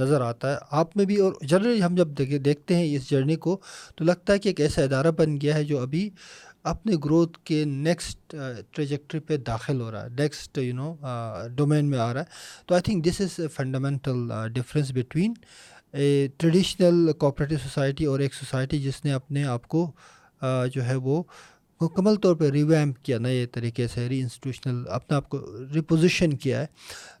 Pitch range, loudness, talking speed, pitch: 130-165 Hz, -25 LUFS, 190 wpm, 145 Hz